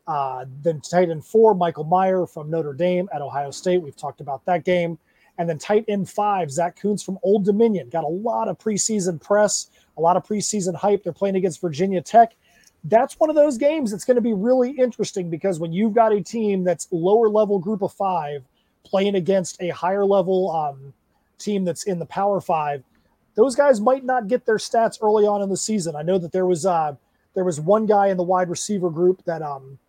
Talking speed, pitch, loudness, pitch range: 215 wpm, 190 Hz, -21 LUFS, 170-210 Hz